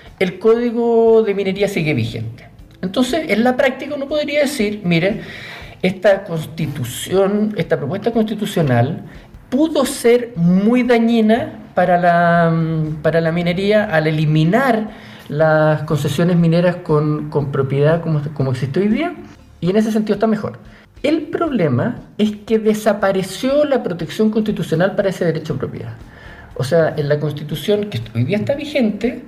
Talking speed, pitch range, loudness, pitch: 145 wpm, 155-225 Hz, -17 LUFS, 190 Hz